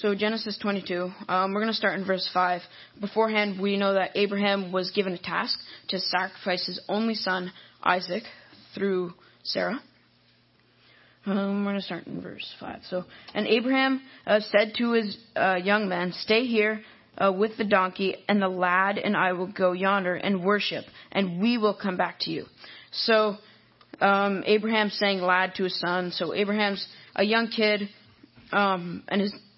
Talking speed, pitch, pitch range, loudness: 170 wpm, 200 Hz, 185-210 Hz, -26 LUFS